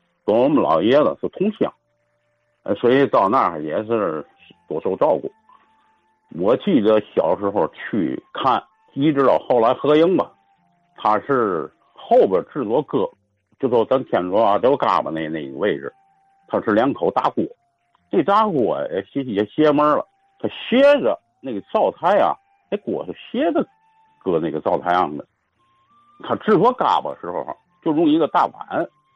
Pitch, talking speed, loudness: 155 Hz, 220 characters per minute, -19 LUFS